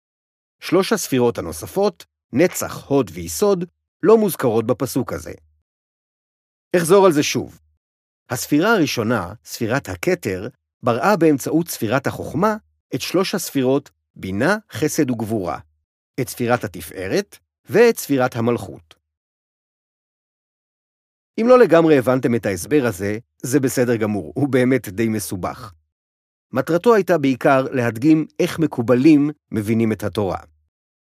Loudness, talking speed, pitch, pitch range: -19 LUFS, 110 wpm, 125 Hz, 95-155 Hz